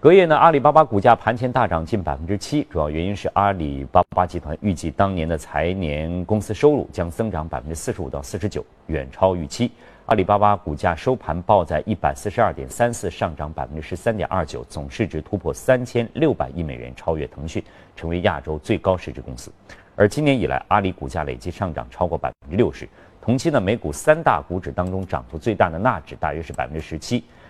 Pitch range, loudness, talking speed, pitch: 80-110 Hz, -21 LUFS, 345 characters per minute, 95 Hz